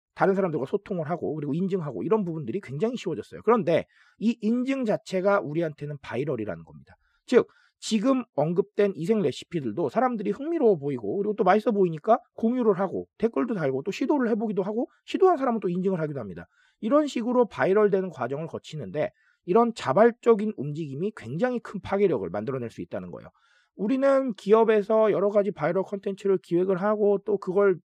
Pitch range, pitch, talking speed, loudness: 190-235 Hz, 205 Hz, 425 characters per minute, -26 LUFS